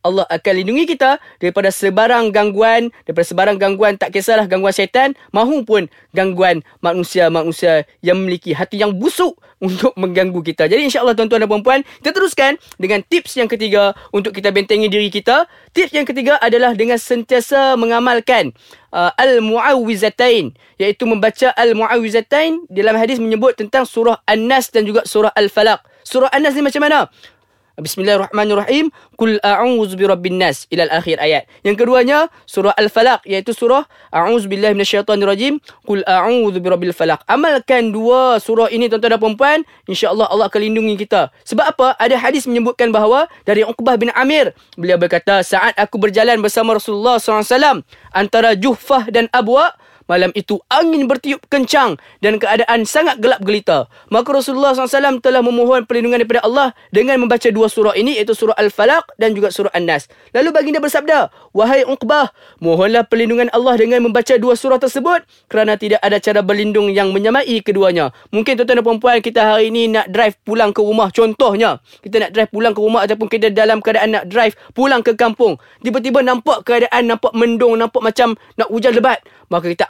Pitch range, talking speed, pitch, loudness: 205-255 Hz, 160 wpm, 225 Hz, -14 LUFS